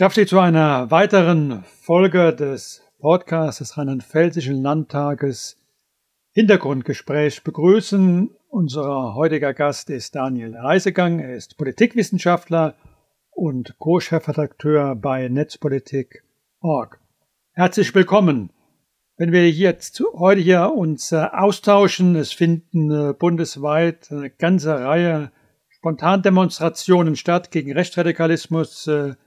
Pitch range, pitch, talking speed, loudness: 145-180 Hz, 160 Hz, 95 wpm, -18 LUFS